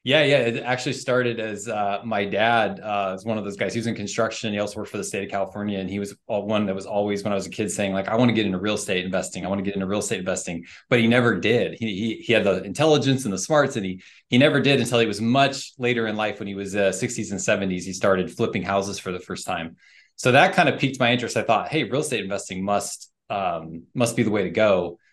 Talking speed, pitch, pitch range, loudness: 280 wpm, 105 Hz, 100-120 Hz, -23 LUFS